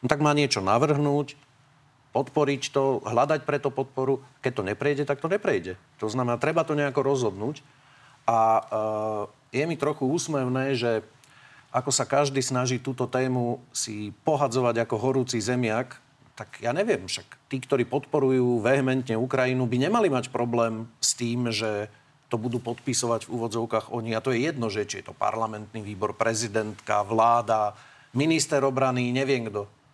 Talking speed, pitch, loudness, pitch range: 155 wpm, 125 Hz, -26 LUFS, 115-140 Hz